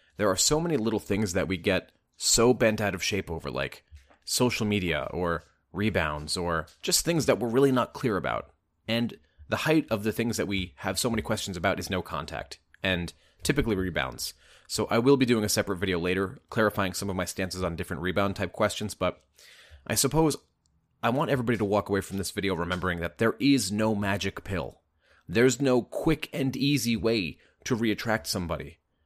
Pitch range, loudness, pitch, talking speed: 90-115 Hz, -27 LUFS, 100 Hz, 195 wpm